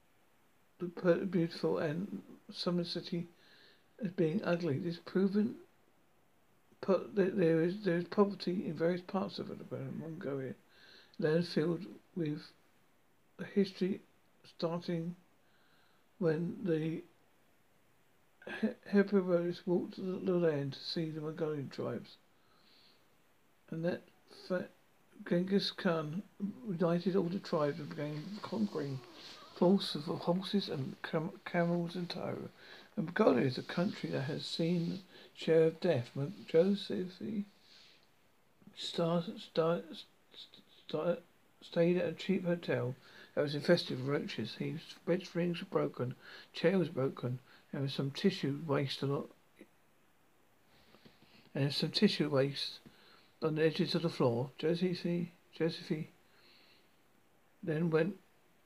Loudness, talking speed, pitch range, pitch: -35 LUFS, 125 wpm, 160-190 Hz, 175 Hz